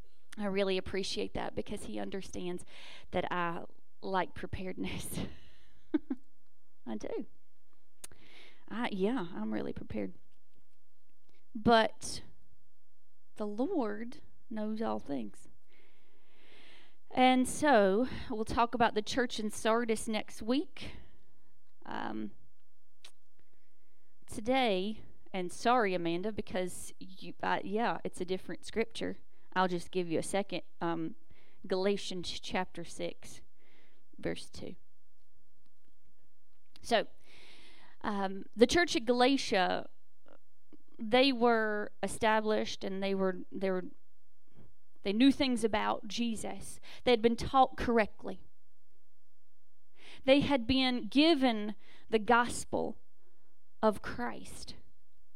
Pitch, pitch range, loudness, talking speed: 215 Hz, 185-245 Hz, -33 LUFS, 100 wpm